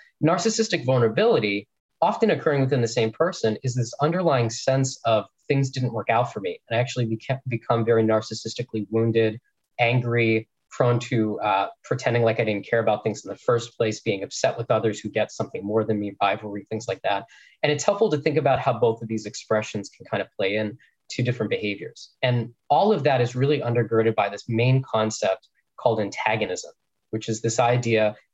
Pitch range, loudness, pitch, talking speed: 110-130 Hz, -24 LUFS, 115 Hz, 195 wpm